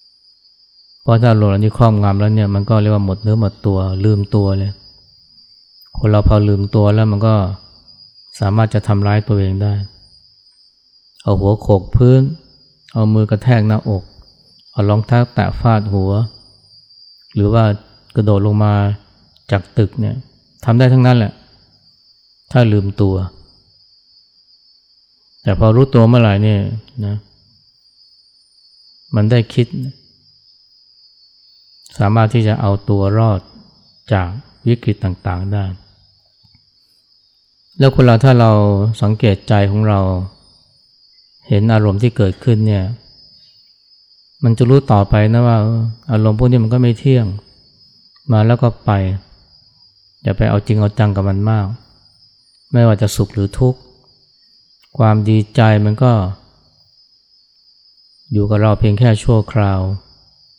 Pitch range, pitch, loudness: 100-115 Hz, 105 Hz, -14 LUFS